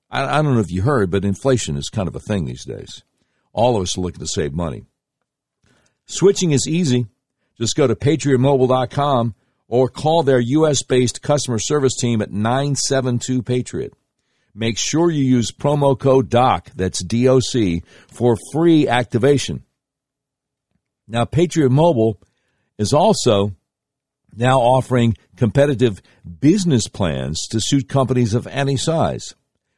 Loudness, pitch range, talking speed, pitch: -18 LUFS, 115-140 Hz, 135 wpm, 130 Hz